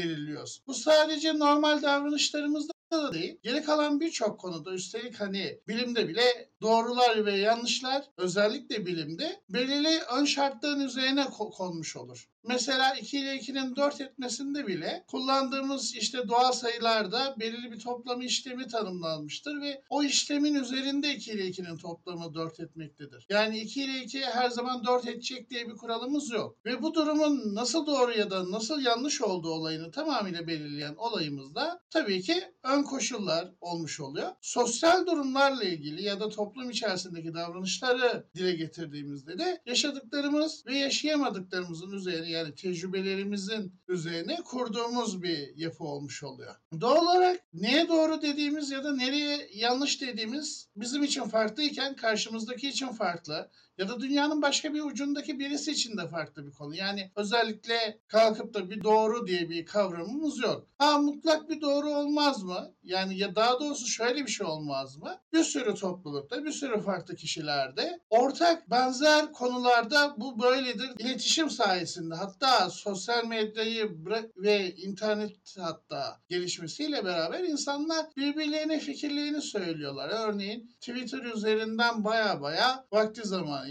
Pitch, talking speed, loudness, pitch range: 235 Hz, 140 wpm, -29 LUFS, 190-280 Hz